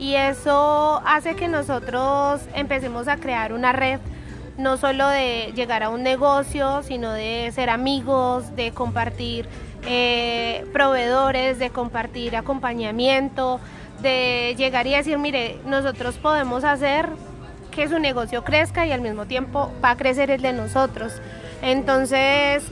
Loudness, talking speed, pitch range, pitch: -21 LUFS, 135 wpm, 245-280 Hz, 265 Hz